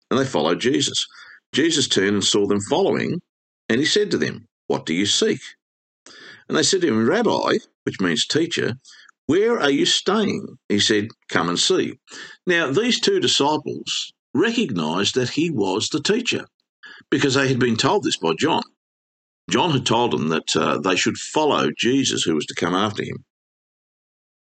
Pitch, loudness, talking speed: 135 Hz, -20 LUFS, 175 wpm